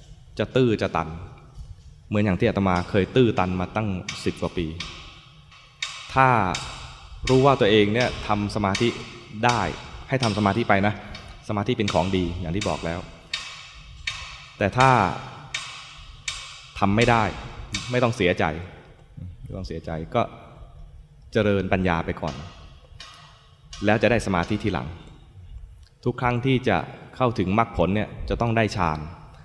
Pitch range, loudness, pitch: 85-115 Hz, -24 LUFS, 100 Hz